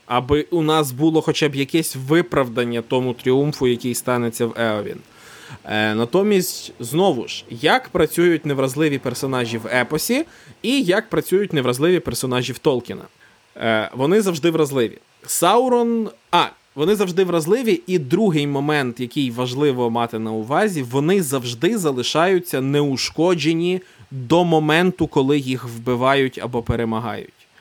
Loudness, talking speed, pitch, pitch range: -19 LUFS, 130 wpm, 145 Hz, 125-170 Hz